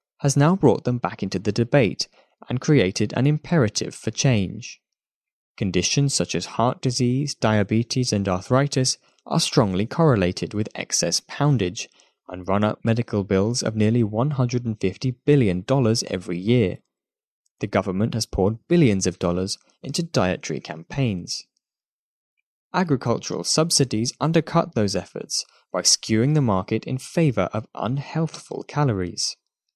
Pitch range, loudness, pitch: 100-140 Hz, -22 LUFS, 115 Hz